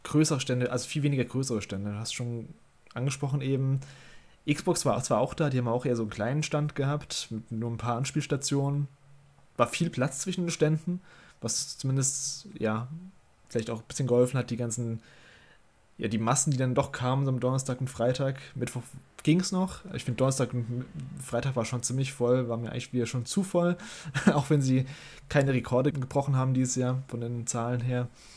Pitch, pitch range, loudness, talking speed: 130 Hz, 120-145 Hz, -29 LUFS, 200 wpm